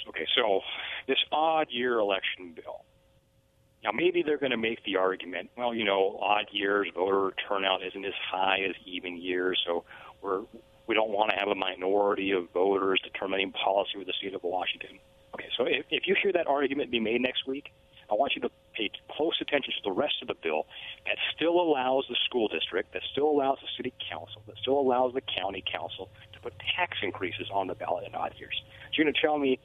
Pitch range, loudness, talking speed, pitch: 95-140 Hz, -29 LUFS, 210 wpm, 120 Hz